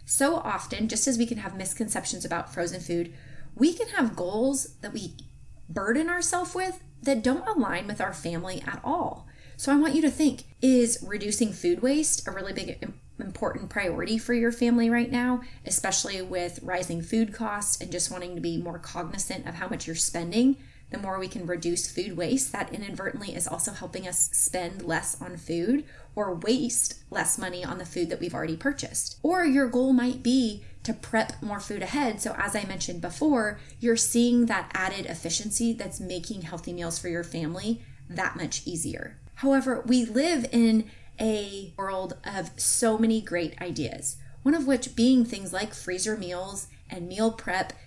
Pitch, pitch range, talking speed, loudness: 215 Hz, 180-250 Hz, 180 wpm, -27 LUFS